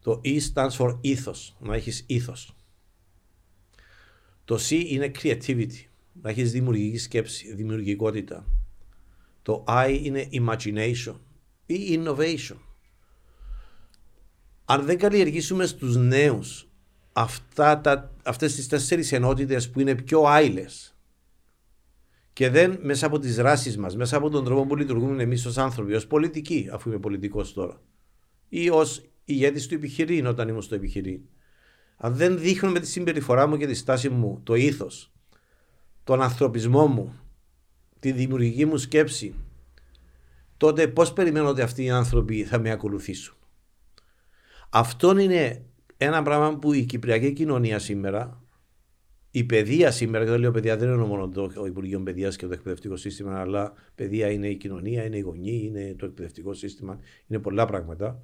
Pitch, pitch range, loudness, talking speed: 120 Hz, 100-140 Hz, -24 LUFS, 145 wpm